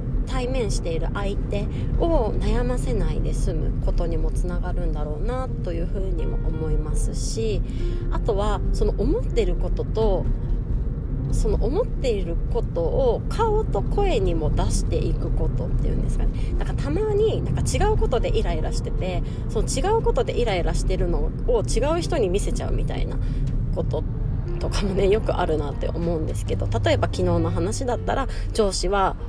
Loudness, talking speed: -25 LUFS, 350 characters per minute